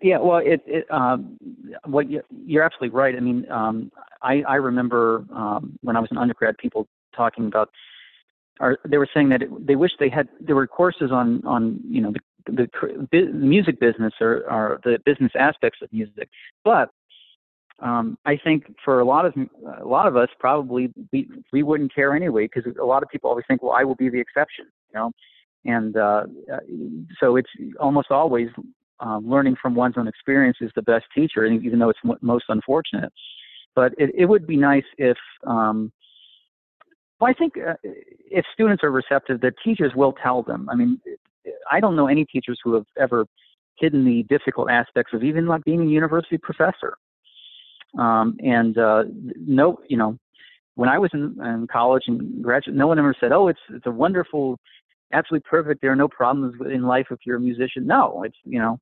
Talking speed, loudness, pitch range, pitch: 195 wpm, -21 LUFS, 120-165 Hz, 135 Hz